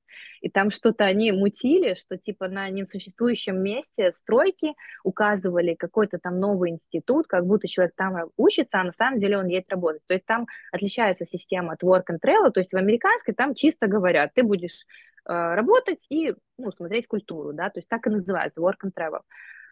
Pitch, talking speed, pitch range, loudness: 195 Hz, 185 wpm, 180-230 Hz, -24 LUFS